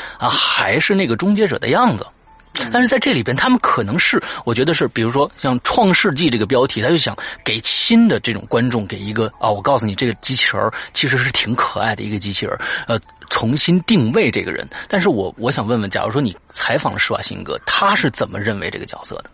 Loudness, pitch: -16 LUFS, 125 Hz